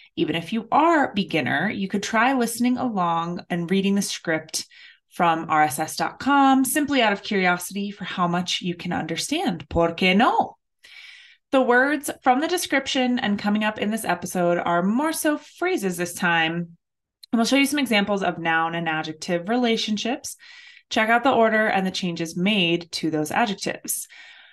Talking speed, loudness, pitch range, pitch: 165 wpm, -22 LUFS, 175-255 Hz, 205 Hz